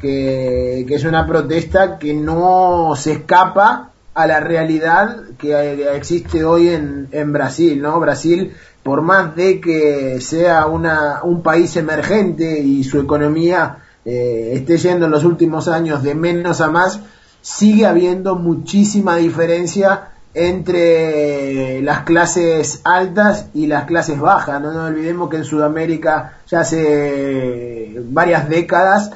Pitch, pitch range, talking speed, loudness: 160 Hz, 150-175 Hz, 135 wpm, -15 LUFS